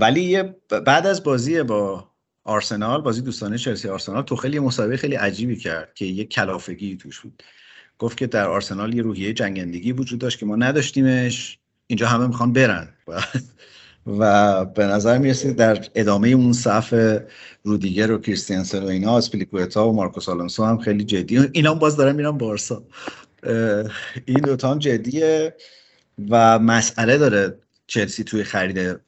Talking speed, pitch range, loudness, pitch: 155 wpm, 105-130 Hz, -20 LUFS, 115 Hz